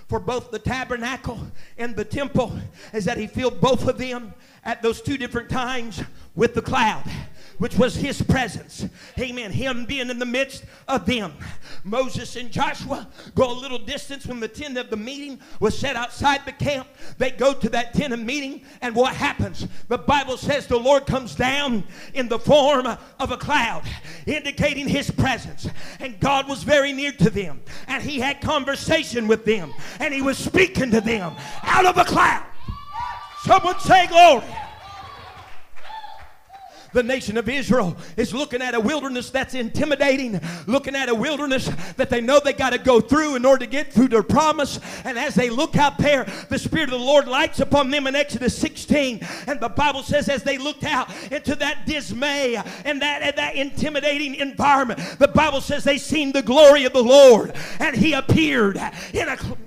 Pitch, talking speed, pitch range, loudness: 265 Hz, 185 wpm, 240-285 Hz, -20 LUFS